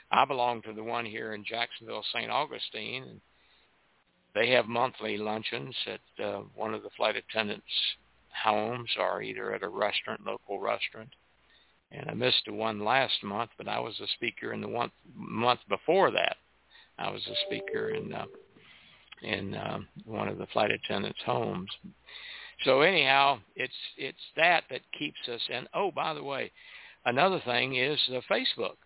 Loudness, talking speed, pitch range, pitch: -30 LUFS, 165 wpm, 110-145 Hz, 120 Hz